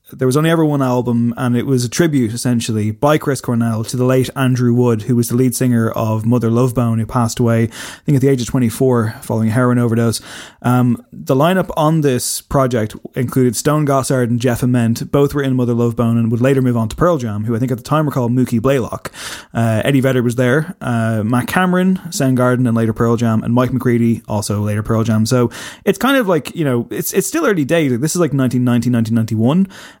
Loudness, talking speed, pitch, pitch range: -15 LUFS, 235 wpm, 125 Hz, 115-135 Hz